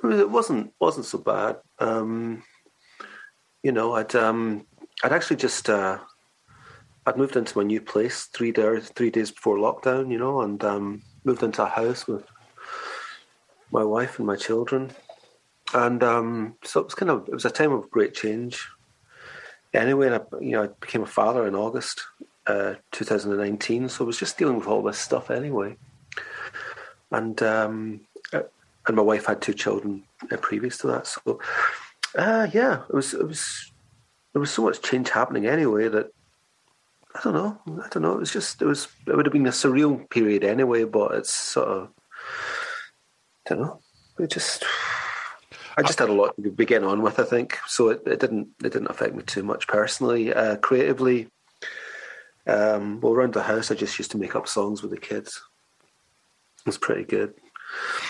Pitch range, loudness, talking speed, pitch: 105-130 Hz, -24 LUFS, 180 wpm, 115 Hz